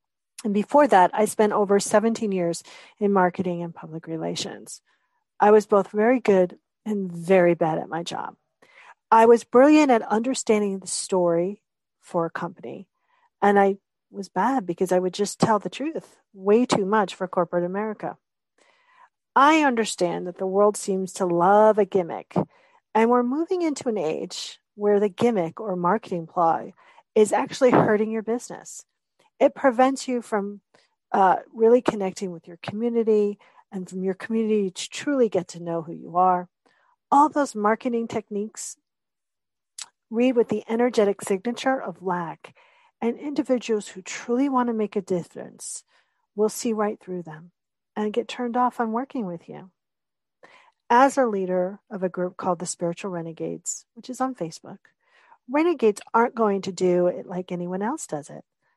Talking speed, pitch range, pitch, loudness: 160 wpm, 185-245 Hz, 210 Hz, -23 LUFS